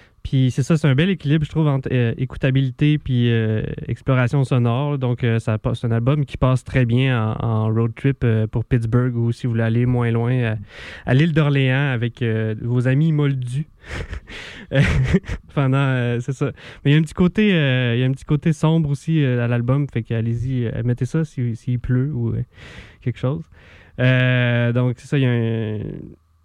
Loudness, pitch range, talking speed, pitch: -20 LUFS, 115-140 Hz, 210 wpm, 125 Hz